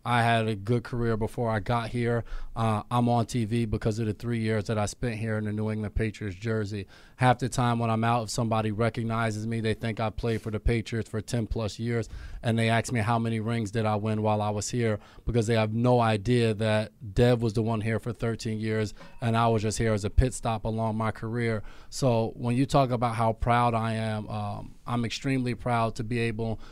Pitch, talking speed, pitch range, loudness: 115 Hz, 235 wpm, 110-120 Hz, -28 LUFS